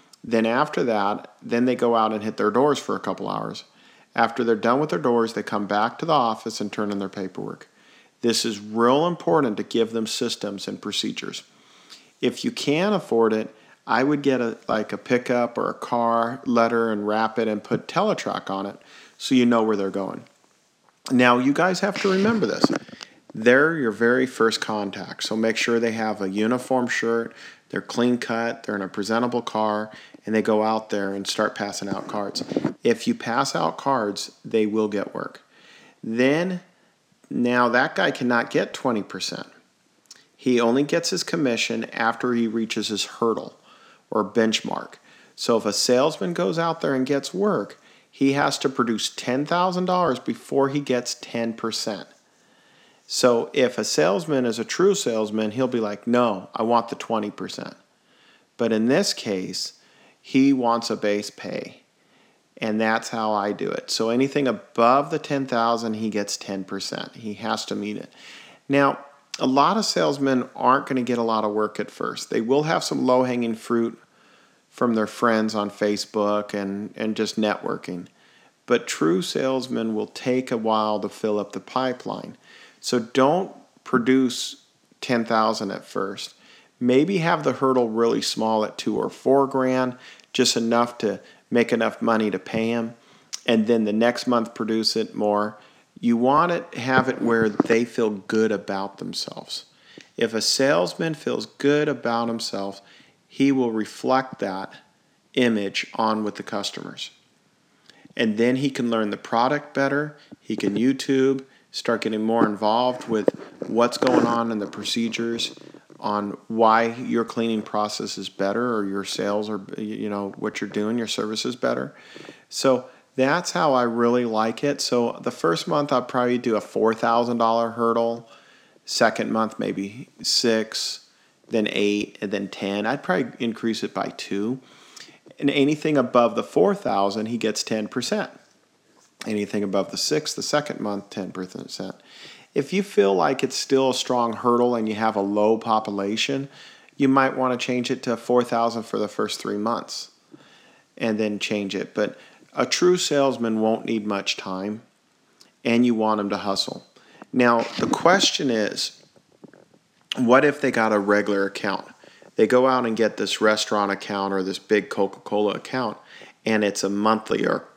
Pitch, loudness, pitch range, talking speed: 115 Hz, -23 LUFS, 105-125 Hz, 170 wpm